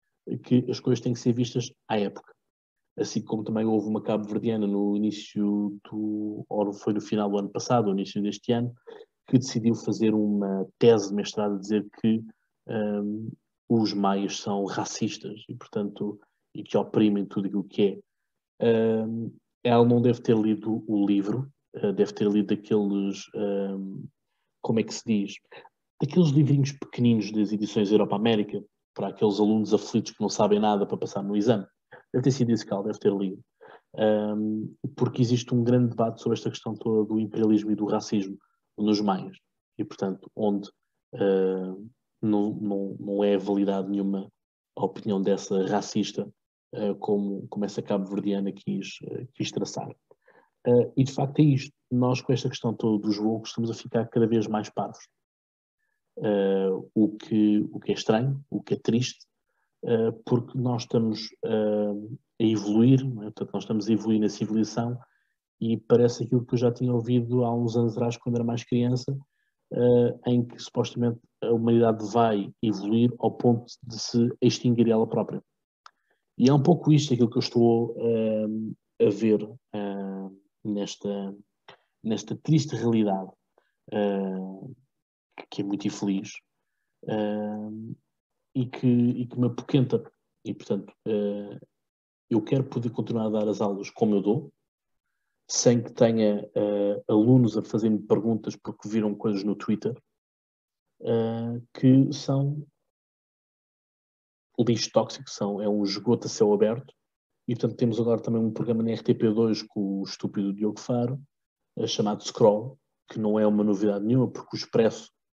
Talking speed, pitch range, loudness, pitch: 155 wpm, 105-120 Hz, -26 LUFS, 110 Hz